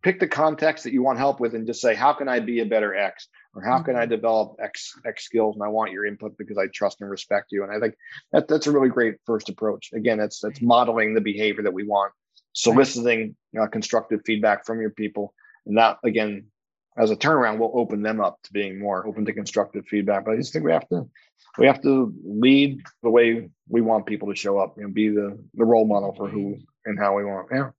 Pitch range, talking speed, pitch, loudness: 105-120 Hz, 245 wpm, 110 Hz, -23 LUFS